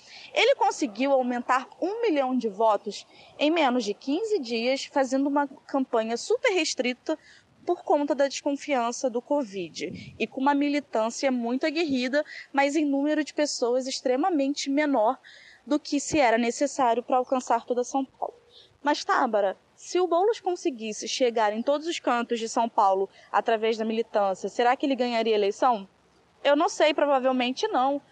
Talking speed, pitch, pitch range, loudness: 160 wpm, 270 Hz, 235-300 Hz, -26 LUFS